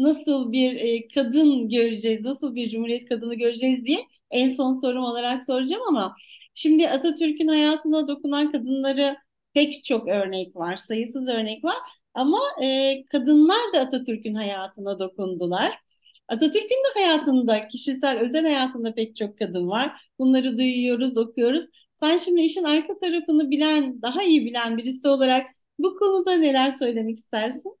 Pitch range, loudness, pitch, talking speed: 235-305 Hz, -23 LUFS, 265 Hz, 135 wpm